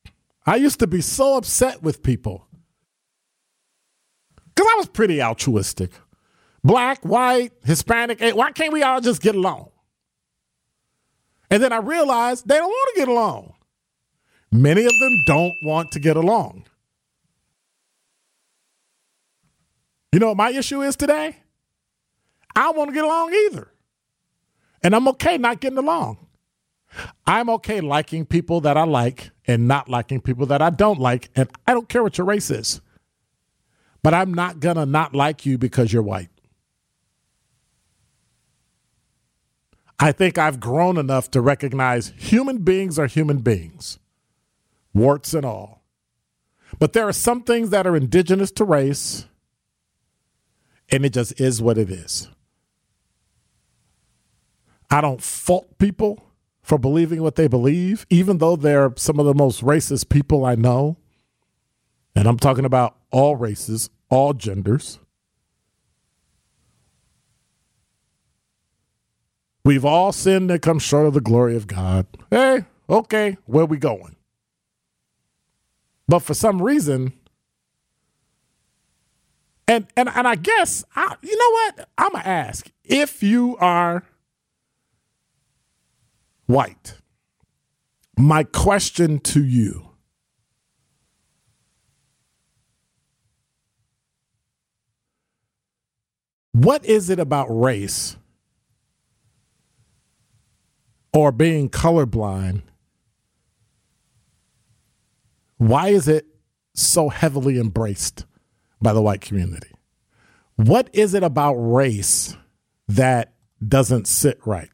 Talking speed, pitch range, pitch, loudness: 115 wpm, 125-205 Hz, 150 Hz, -19 LUFS